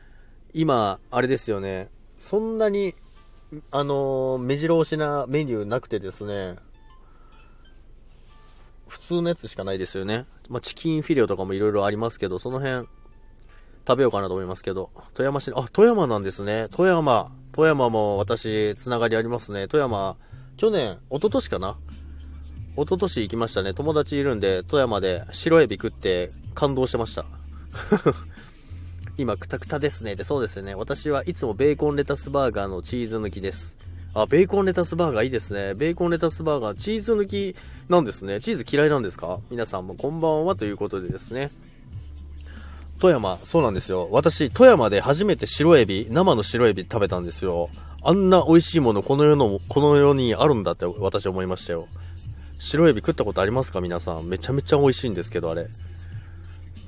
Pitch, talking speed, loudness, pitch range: 110 Hz, 365 characters per minute, -23 LUFS, 95-145 Hz